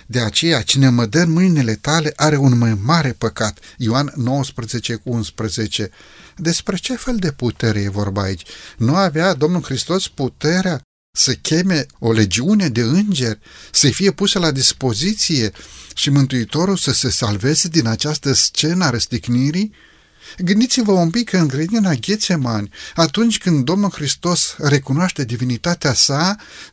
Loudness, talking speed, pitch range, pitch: -16 LUFS, 140 wpm, 120-175 Hz, 145 Hz